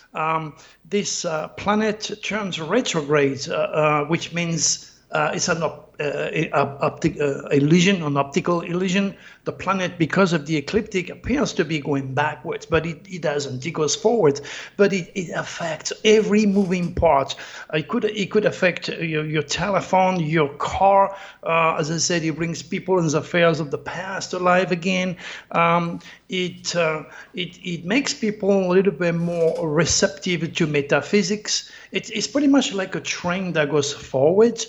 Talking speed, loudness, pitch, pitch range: 165 wpm, -21 LUFS, 175 Hz, 155-195 Hz